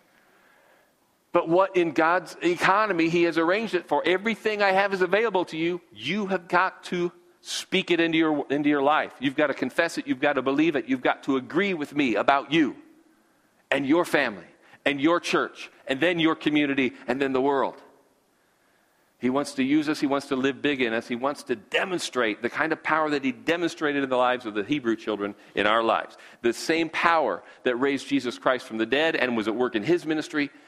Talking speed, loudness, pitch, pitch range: 215 wpm, -25 LUFS, 155 Hz, 135-180 Hz